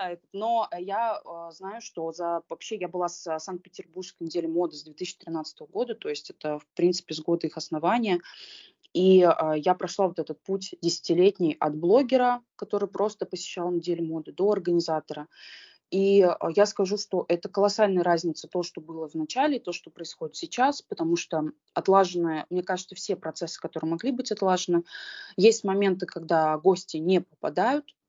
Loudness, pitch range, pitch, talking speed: -27 LUFS, 165-205 Hz, 180 Hz, 155 wpm